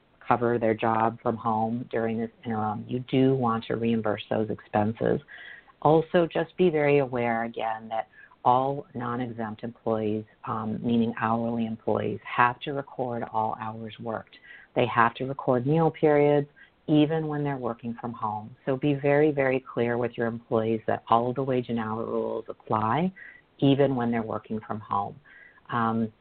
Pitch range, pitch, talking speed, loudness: 110-135 Hz, 115 Hz, 165 wpm, -27 LUFS